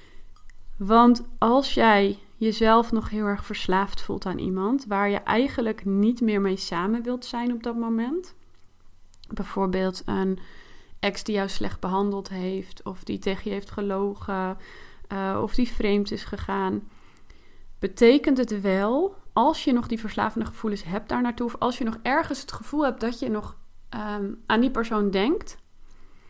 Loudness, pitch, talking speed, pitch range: -25 LUFS, 210 Hz, 160 wpm, 195-240 Hz